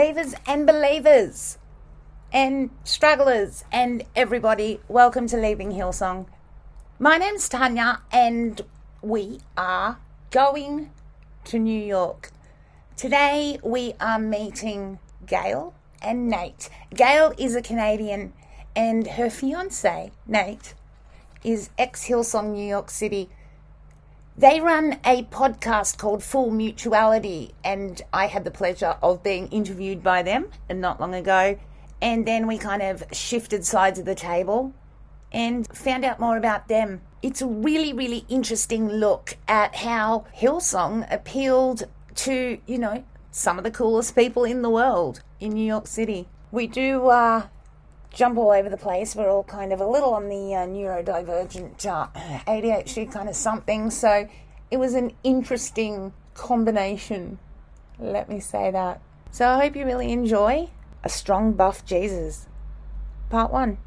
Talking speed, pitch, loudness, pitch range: 140 wpm, 220 Hz, -23 LUFS, 200-250 Hz